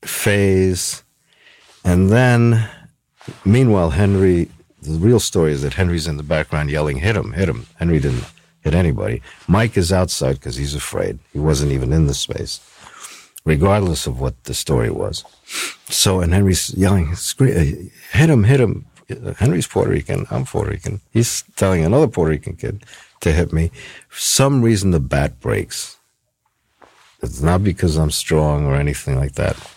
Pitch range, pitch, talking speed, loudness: 80-110 Hz, 95 Hz, 160 wpm, -18 LUFS